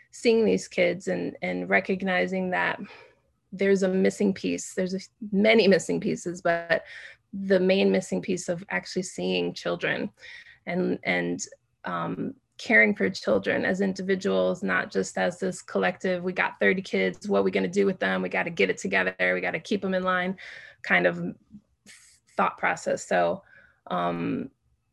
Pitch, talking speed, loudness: 185 Hz, 165 wpm, -26 LUFS